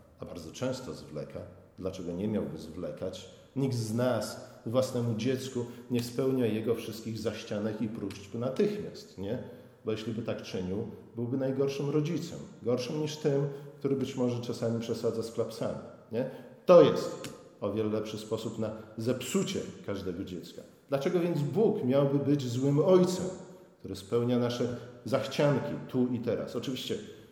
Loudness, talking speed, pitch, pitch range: -31 LUFS, 145 wpm, 120 Hz, 110-140 Hz